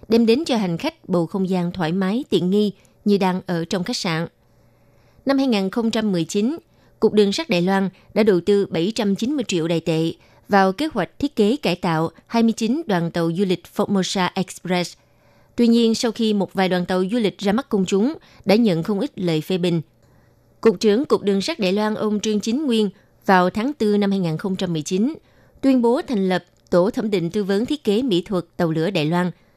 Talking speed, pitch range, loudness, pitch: 205 wpm, 175-220 Hz, -20 LUFS, 195 Hz